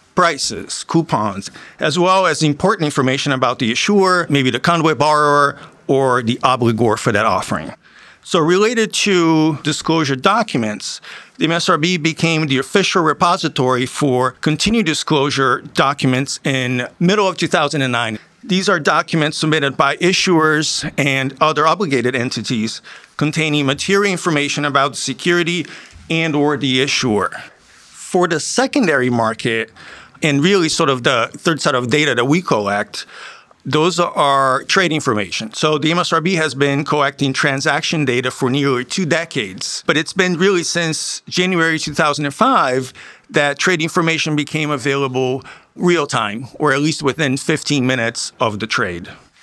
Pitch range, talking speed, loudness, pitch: 135-170 Hz, 140 wpm, -16 LUFS, 150 Hz